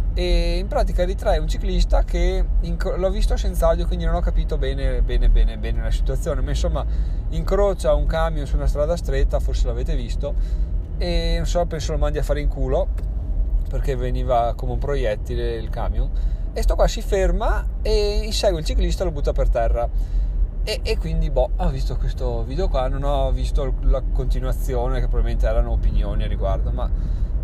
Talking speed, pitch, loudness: 185 wpm, 120 Hz, -23 LUFS